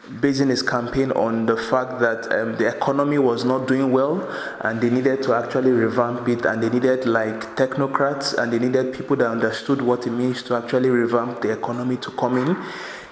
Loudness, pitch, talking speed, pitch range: -21 LUFS, 125 Hz, 195 wpm, 120-130 Hz